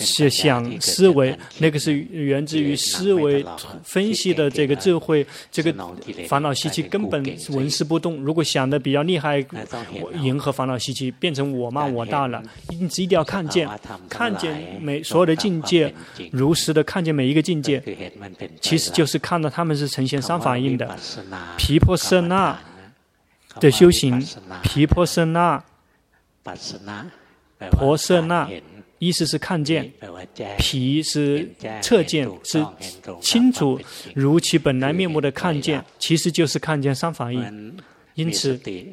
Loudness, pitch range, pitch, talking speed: -20 LUFS, 135-165 Hz, 150 Hz, 215 characters per minute